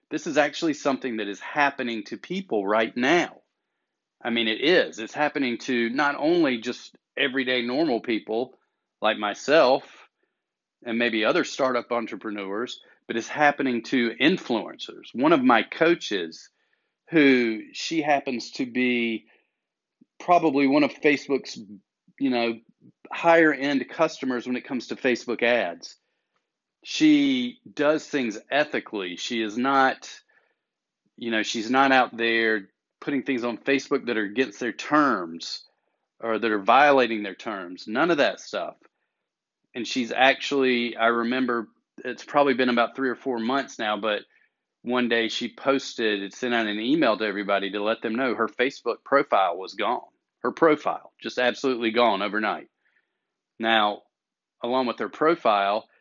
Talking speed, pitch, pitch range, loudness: 145 wpm, 125 Hz, 115-140 Hz, -24 LUFS